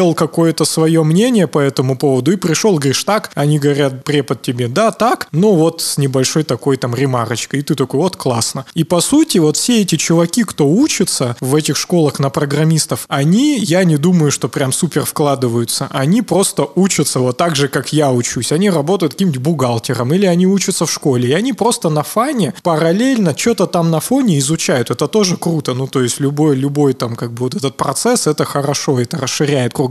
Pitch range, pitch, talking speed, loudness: 135-180 Hz, 155 Hz, 195 wpm, -14 LUFS